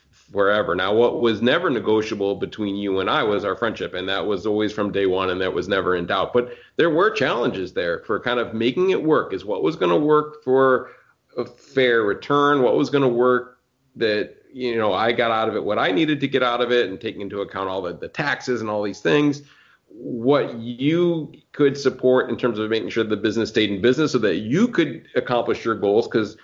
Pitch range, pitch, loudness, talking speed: 105-130 Hz, 120 Hz, -21 LUFS, 230 wpm